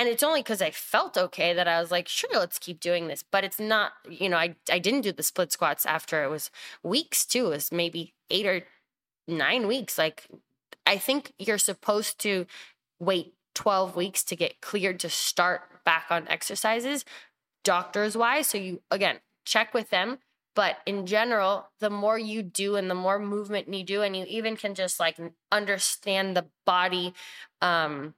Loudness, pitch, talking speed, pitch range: -27 LUFS, 195 Hz, 185 wpm, 175-215 Hz